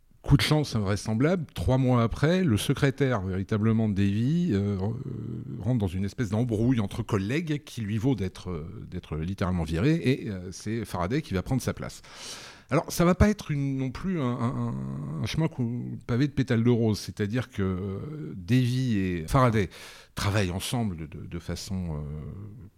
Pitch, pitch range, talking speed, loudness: 115 Hz, 100-130 Hz, 170 wpm, -27 LUFS